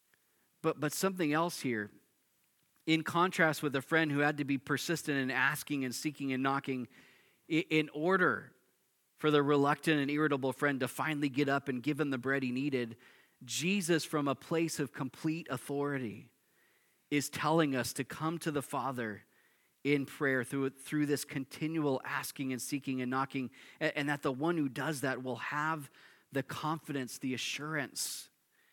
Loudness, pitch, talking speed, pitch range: -34 LUFS, 145 Hz, 170 wpm, 135-155 Hz